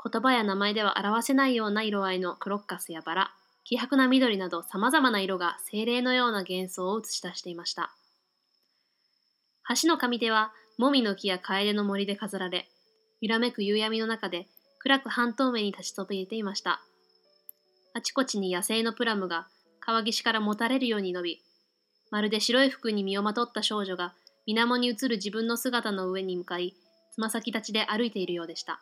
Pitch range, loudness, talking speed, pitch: 185-235 Hz, -28 LUFS, 355 characters per minute, 210 Hz